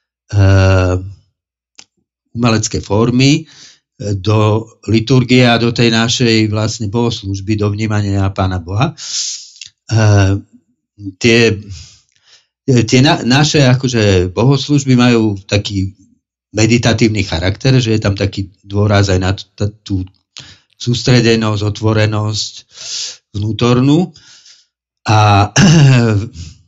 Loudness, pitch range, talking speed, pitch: -13 LUFS, 100-120 Hz, 90 wpm, 110 Hz